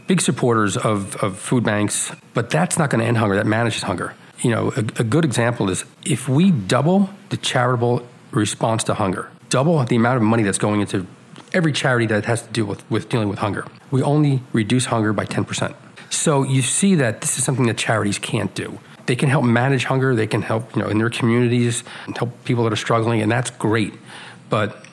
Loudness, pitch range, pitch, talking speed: -20 LUFS, 110-140 Hz, 120 Hz, 215 wpm